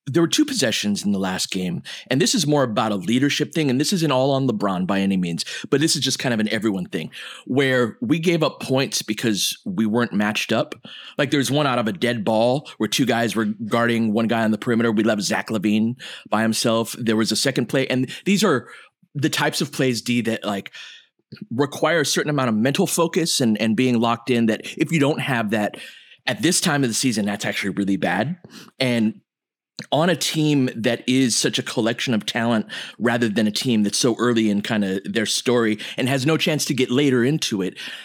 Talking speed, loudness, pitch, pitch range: 225 wpm, -21 LUFS, 120 Hz, 110-145 Hz